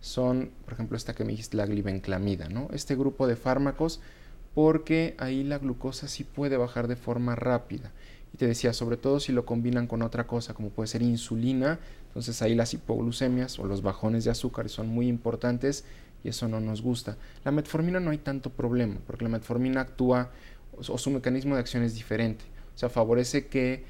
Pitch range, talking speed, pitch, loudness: 115-130 Hz, 195 wpm, 120 Hz, -29 LUFS